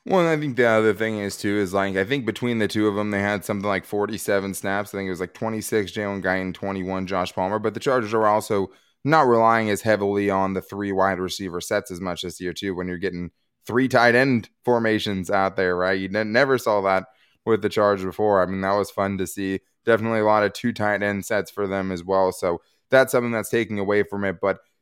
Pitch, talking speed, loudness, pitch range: 100 Hz, 245 wpm, -22 LUFS, 95-110 Hz